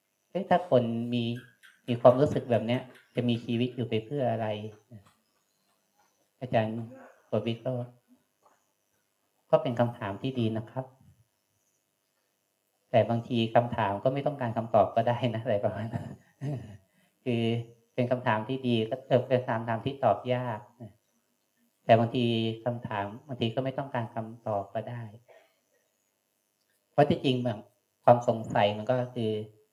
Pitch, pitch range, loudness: 120 Hz, 115-125 Hz, -29 LUFS